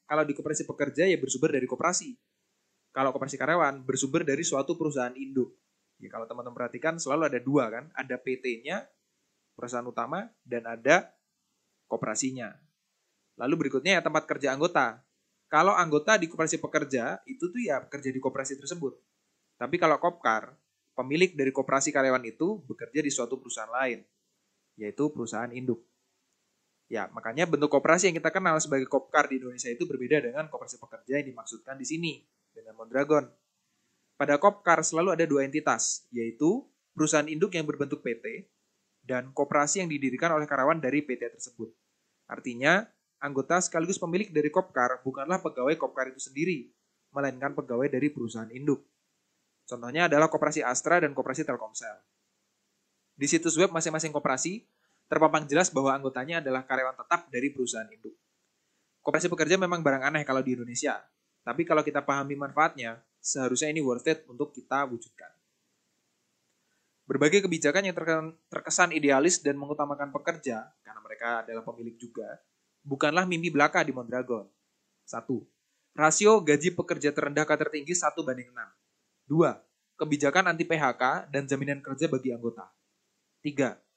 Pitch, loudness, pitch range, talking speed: 145 Hz, -28 LUFS, 130-160 Hz, 145 wpm